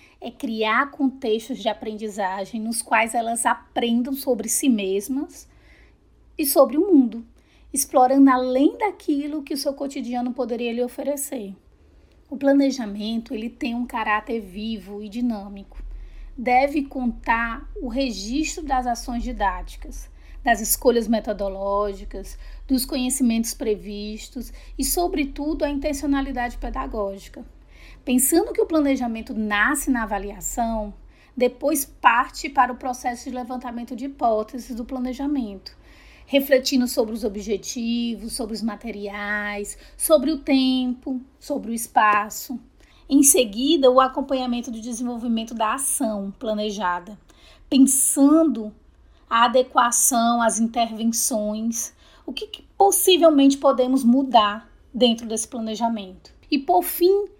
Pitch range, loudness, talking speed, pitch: 225-275 Hz, -22 LUFS, 115 wpm, 245 Hz